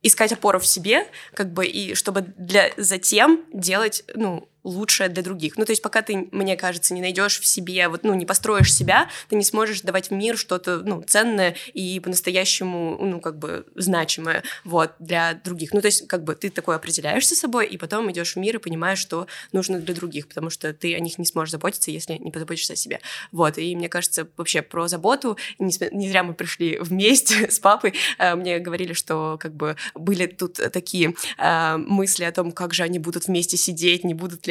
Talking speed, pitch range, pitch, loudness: 210 wpm, 170-200 Hz, 180 Hz, -21 LUFS